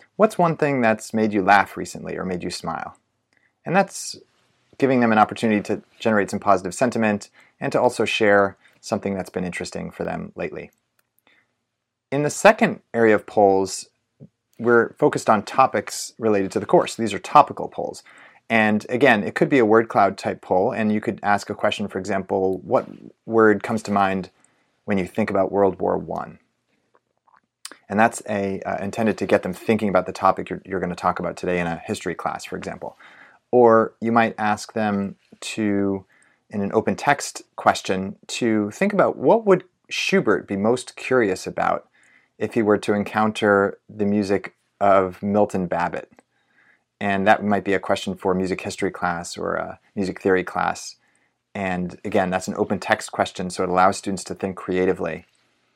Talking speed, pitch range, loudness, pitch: 180 wpm, 95-110 Hz, -21 LUFS, 100 Hz